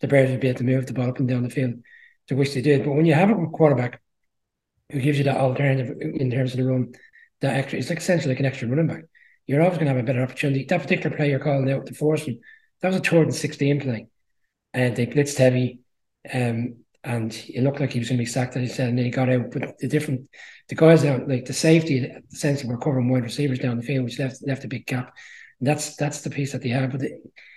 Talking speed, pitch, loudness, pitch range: 265 wpm, 135 Hz, -23 LUFS, 125-145 Hz